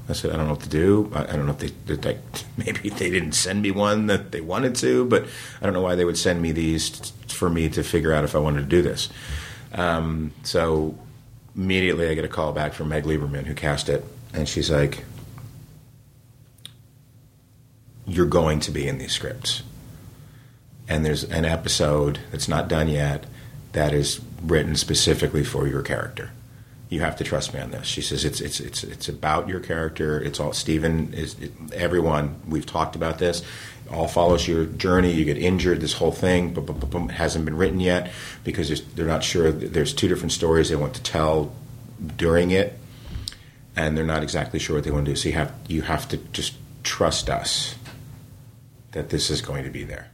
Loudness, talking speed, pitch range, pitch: -24 LUFS, 200 wpm, 75-120 Hz, 85 Hz